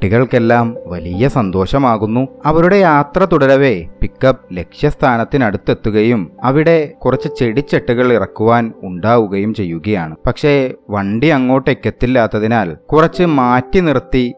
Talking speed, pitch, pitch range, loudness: 85 wpm, 125 Hz, 110-145 Hz, -13 LUFS